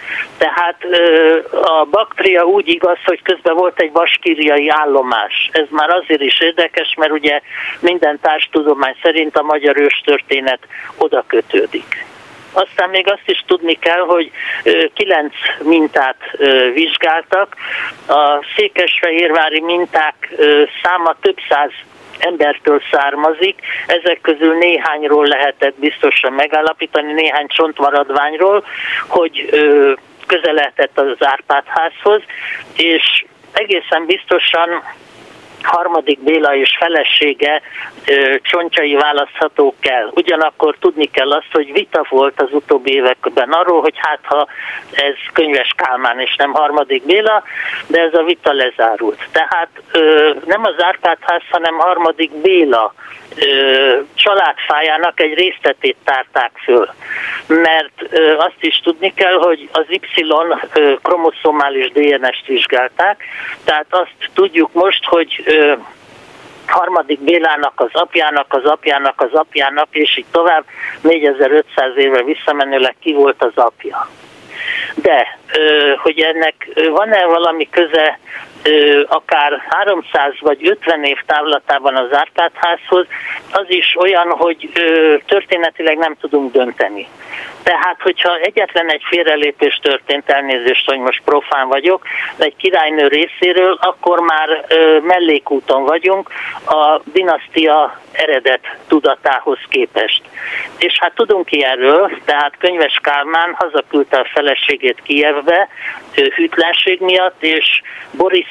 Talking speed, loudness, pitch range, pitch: 110 wpm, -13 LUFS, 150-190 Hz, 165 Hz